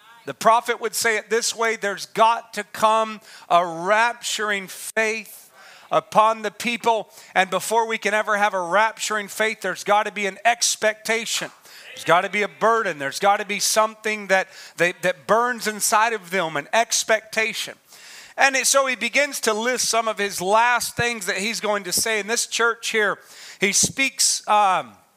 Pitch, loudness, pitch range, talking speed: 215 Hz, -21 LUFS, 200-230 Hz, 180 wpm